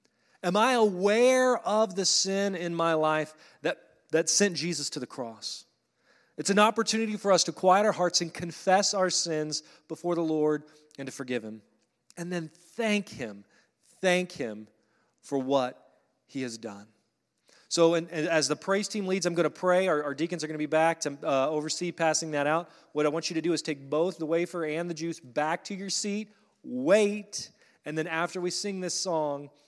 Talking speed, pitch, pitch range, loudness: 195 wpm, 165 Hz, 155-190 Hz, -28 LUFS